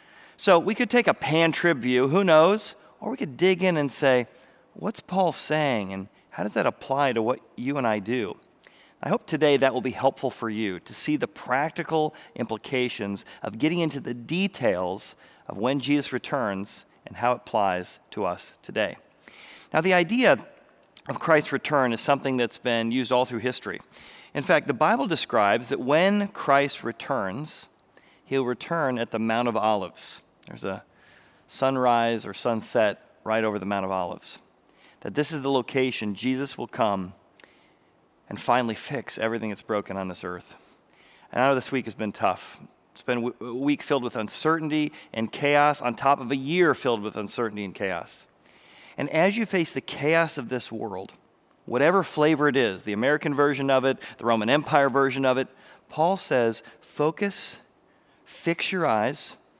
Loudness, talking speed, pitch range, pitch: -25 LUFS, 175 wpm, 115-150 Hz, 130 Hz